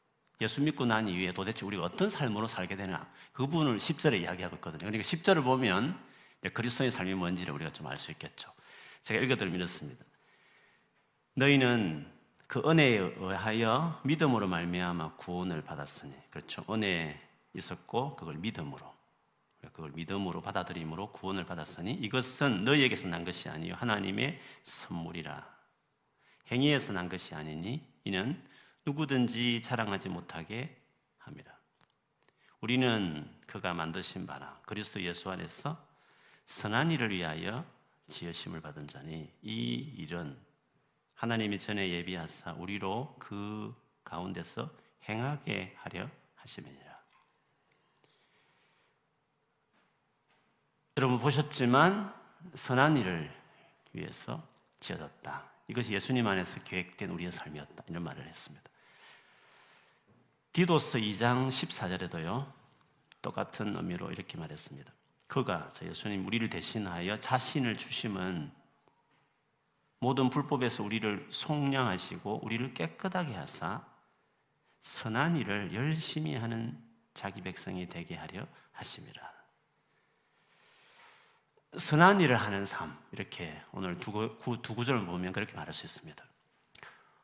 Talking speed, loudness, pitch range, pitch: 280 characters per minute, -33 LUFS, 90-135 Hz, 110 Hz